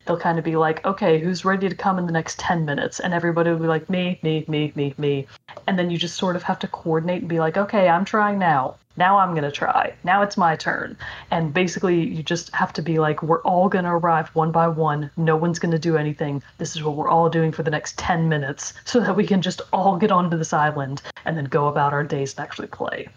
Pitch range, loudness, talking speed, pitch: 155-185 Hz, -21 LUFS, 265 wpm, 165 Hz